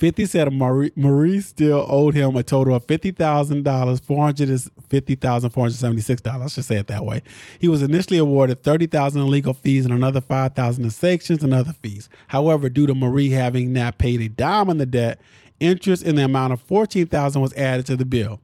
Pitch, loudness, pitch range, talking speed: 135 Hz, -20 LUFS, 125-150 Hz, 230 wpm